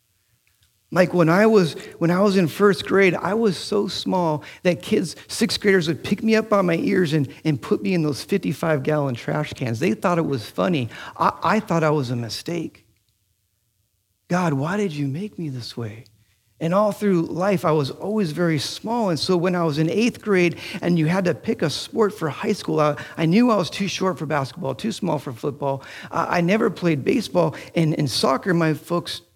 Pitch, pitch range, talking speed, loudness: 165 Hz, 140-195 Hz, 215 wpm, -21 LUFS